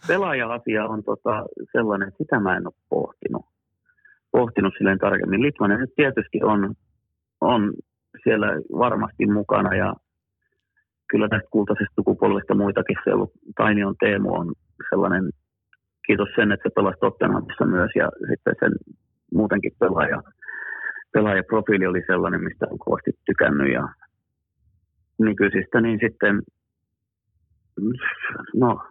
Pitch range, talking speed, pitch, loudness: 95-110 Hz, 115 wpm, 100 Hz, -22 LUFS